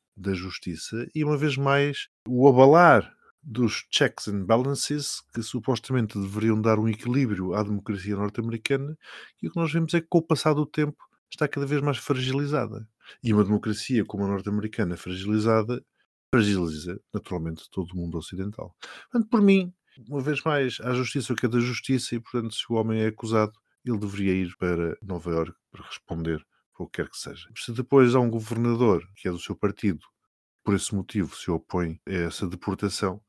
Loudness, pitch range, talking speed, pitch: -26 LUFS, 100-135 Hz, 180 wpm, 110 Hz